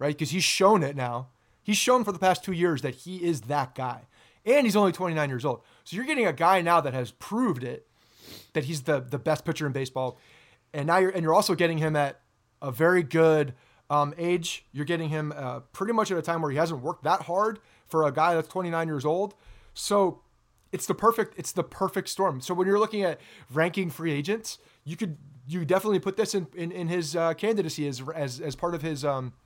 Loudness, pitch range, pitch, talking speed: -27 LUFS, 145-190 Hz, 165 Hz, 230 wpm